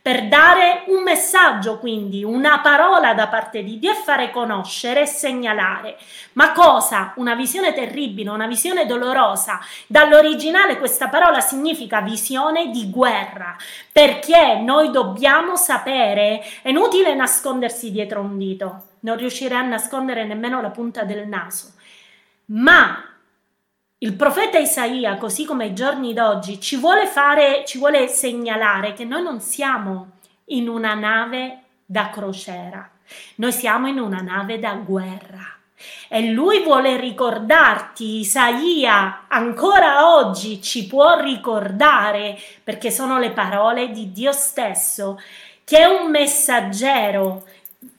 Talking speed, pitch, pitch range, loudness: 130 wpm, 245 Hz, 210-290 Hz, -16 LUFS